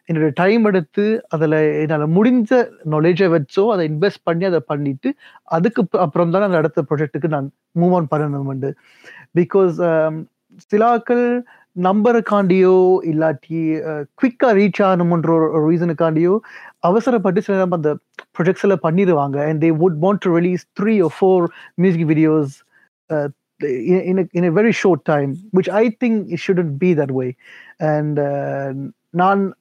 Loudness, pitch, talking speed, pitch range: -17 LUFS, 175 Hz, 120 wpm, 155-195 Hz